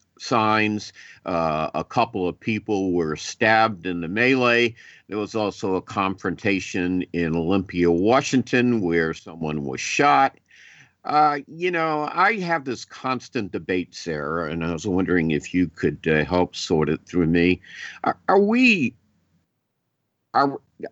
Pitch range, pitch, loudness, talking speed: 85-120 Hz, 95 Hz, -22 LUFS, 140 wpm